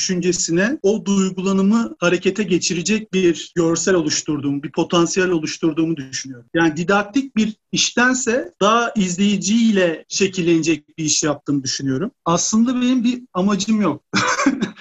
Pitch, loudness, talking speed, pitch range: 185 Hz, -18 LUFS, 115 wpm, 165-215 Hz